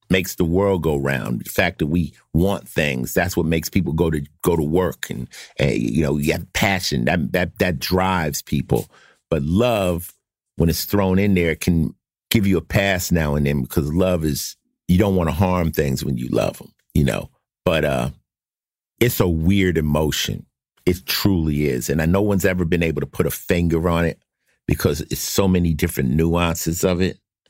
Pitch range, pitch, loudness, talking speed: 75-95 Hz, 85 Hz, -20 LUFS, 195 wpm